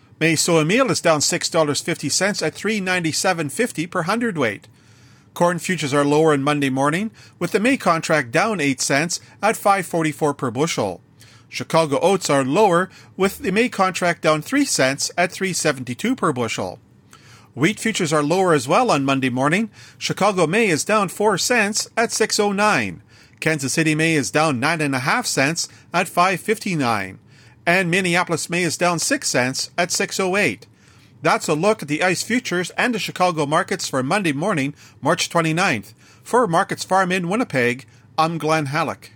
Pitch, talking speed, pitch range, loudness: 165 Hz, 155 wpm, 140-190 Hz, -19 LUFS